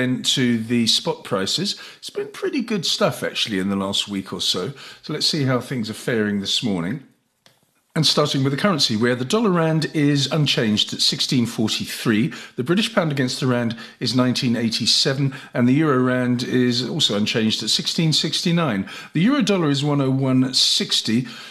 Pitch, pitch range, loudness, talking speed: 130 Hz, 120-160 Hz, -20 LUFS, 165 wpm